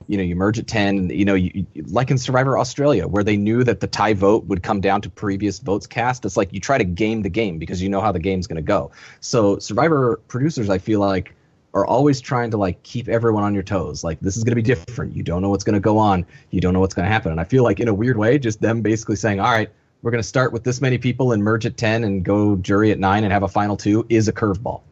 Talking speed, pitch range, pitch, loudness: 295 wpm, 100-120 Hz, 105 Hz, -19 LUFS